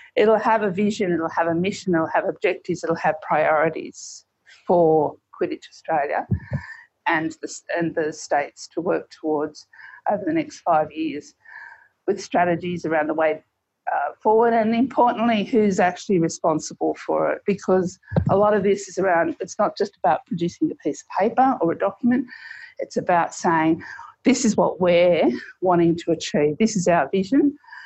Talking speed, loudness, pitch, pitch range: 165 wpm, -22 LUFS, 185 Hz, 165-225 Hz